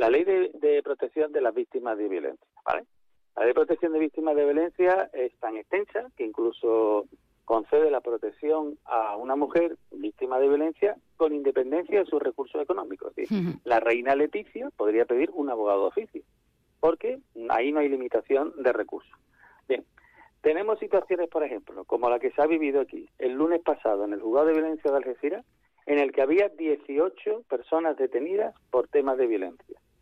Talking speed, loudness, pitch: 180 wpm, -27 LUFS, 185 Hz